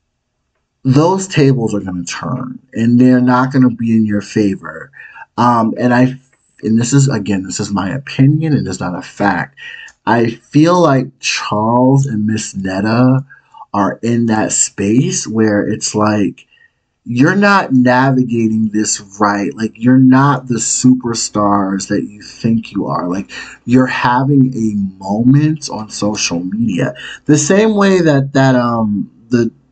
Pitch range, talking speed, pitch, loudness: 110-135 Hz, 150 wpm, 120 Hz, -13 LUFS